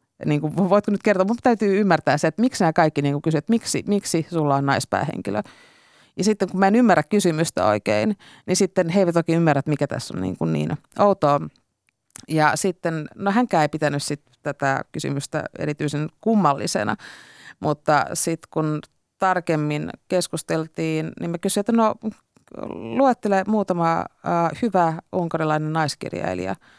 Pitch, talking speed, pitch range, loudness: 165 Hz, 150 wpm, 150-195 Hz, -22 LUFS